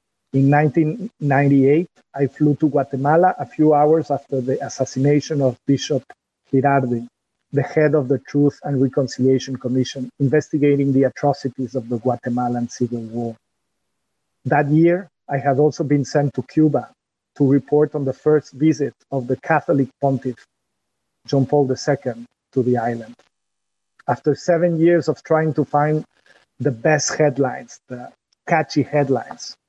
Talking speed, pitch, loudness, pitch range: 140 wpm, 140 Hz, -19 LUFS, 130-150 Hz